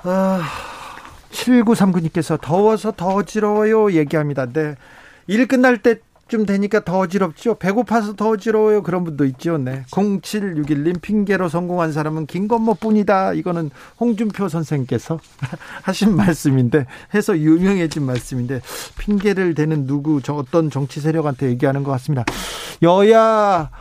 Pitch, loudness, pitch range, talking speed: 180 Hz, -18 LUFS, 150-210 Hz, 300 characters per minute